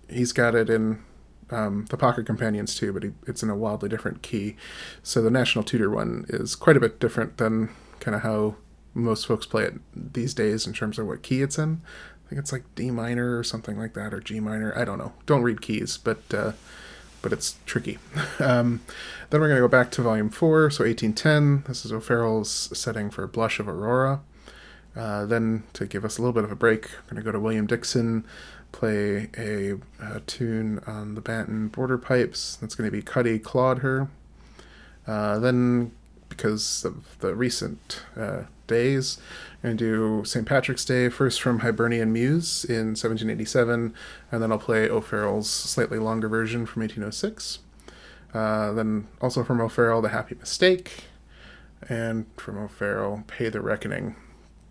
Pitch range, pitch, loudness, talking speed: 110-125 Hz, 115 Hz, -26 LUFS, 180 wpm